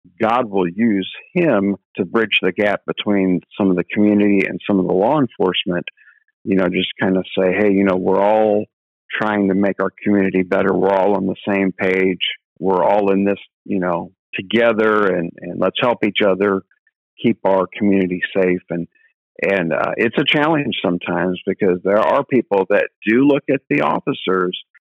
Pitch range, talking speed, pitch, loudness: 95-105 Hz, 185 wpm, 95 Hz, -17 LUFS